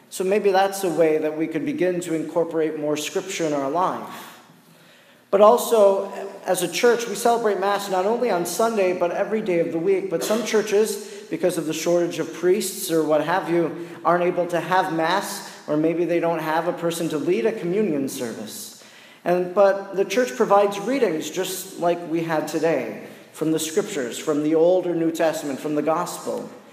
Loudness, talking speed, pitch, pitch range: -22 LUFS, 195 wpm, 175 Hz, 160-200 Hz